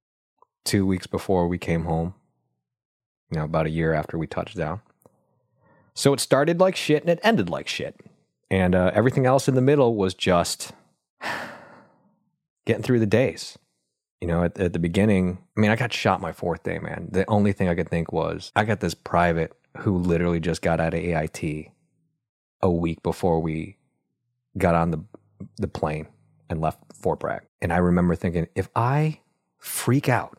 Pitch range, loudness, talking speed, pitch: 85-120 Hz, -24 LUFS, 180 wpm, 95 Hz